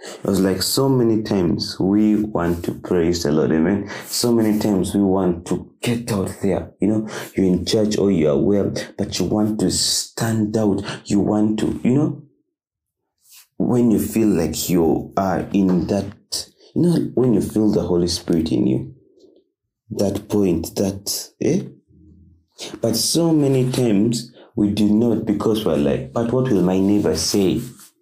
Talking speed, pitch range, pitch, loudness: 175 wpm, 90-110 Hz, 105 Hz, -19 LUFS